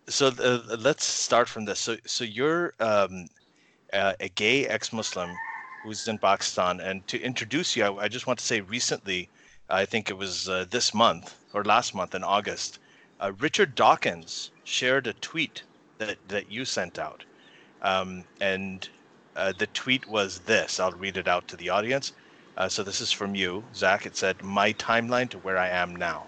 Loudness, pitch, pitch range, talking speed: -27 LUFS, 100 Hz, 95-115 Hz, 185 wpm